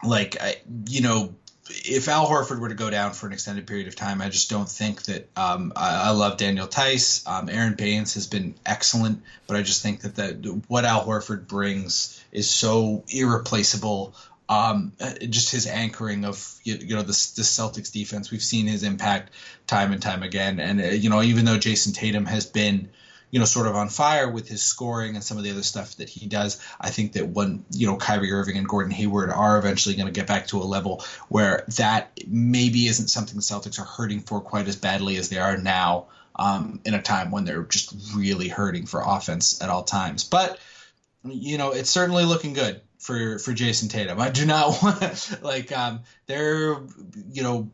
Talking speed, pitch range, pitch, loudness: 205 wpm, 100-120 Hz, 105 Hz, -23 LUFS